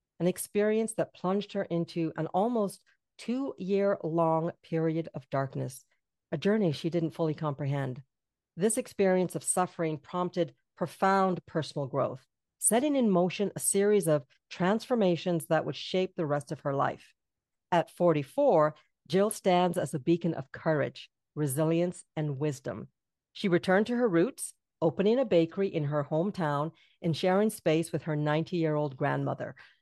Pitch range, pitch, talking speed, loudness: 155-190 Hz, 170 Hz, 150 wpm, -30 LUFS